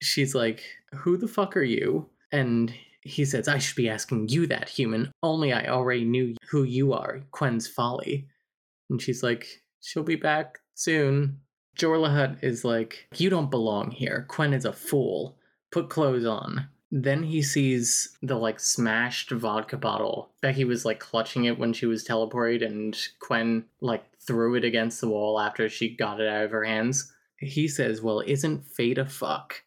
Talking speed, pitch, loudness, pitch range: 180 wpm, 125 Hz, -27 LUFS, 115-145 Hz